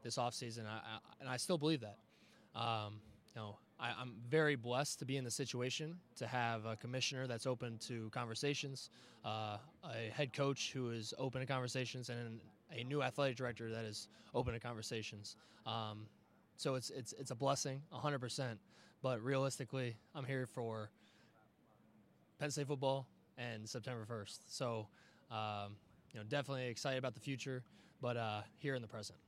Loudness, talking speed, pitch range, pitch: -43 LUFS, 165 wpm, 110-135 Hz, 120 Hz